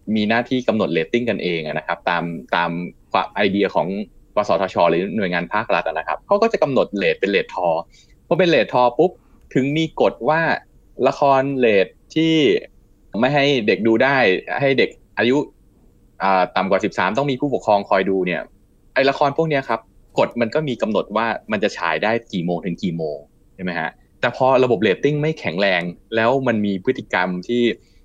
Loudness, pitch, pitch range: -19 LUFS, 115 Hz, 95-140 Hz